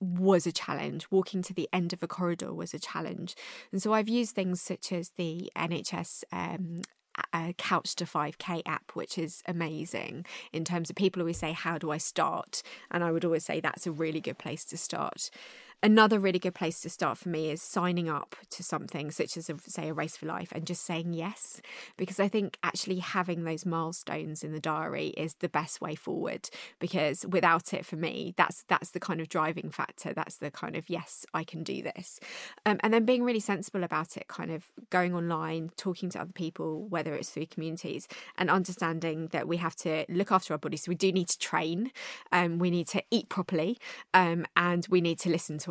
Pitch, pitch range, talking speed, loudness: 175 Hz, 165-185 Hz, 215 wpm, -31 LUFS